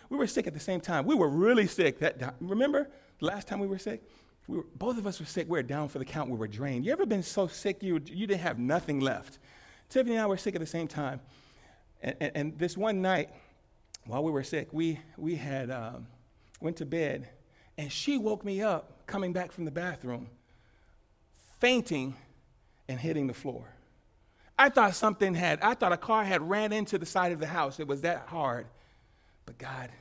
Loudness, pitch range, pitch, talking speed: -31 LUFS, 135-195 Hz, 165 Hz, 220 wpm